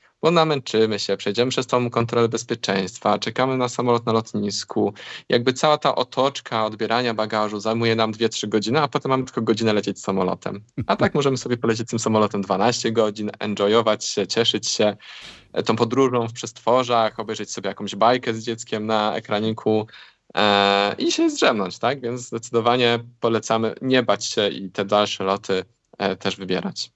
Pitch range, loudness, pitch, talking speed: 105-120 Hz, -21 LUFS, 115 Hz, 165 wpm